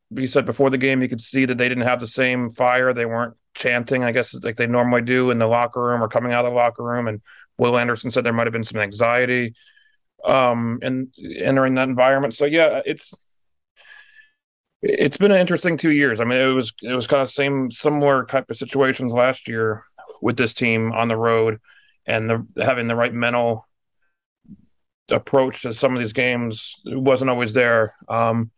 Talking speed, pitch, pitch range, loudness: 200 wpm, 125 Hz, 115-135 Hz, -20 LUFS